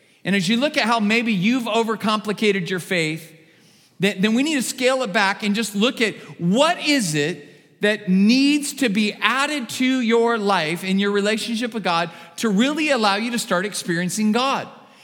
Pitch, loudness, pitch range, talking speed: 215 Hz, -20 LUFS, 190-240 Hz, 185 wpm